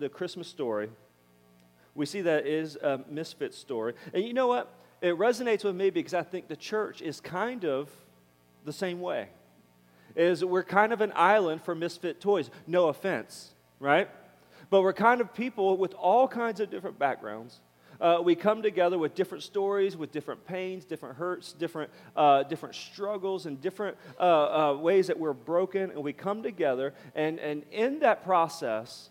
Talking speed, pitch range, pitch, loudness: 180 wpm, 145-195 Hz, 175 Hz, -29 LUFS